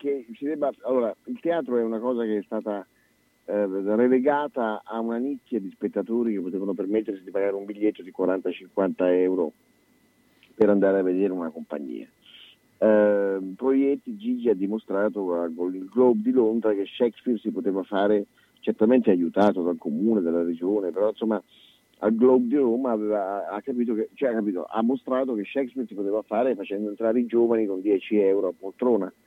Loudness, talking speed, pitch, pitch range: -25 LUFS, 175 wpm, 105 Hz, 100-120 Hz